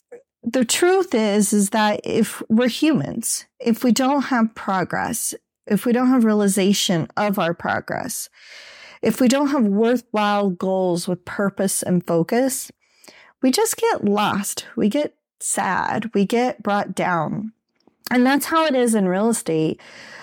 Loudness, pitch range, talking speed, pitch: -20 LUFS, 200-260 Hz, 150 wpm, 225 Hz